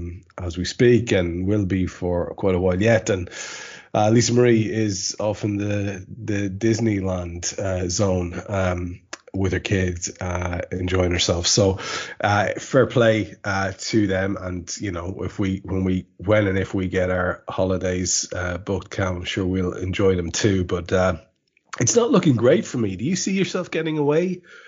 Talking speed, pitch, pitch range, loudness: 180 wpm, 95 Hz, 90-110 Hz, -22 LUFS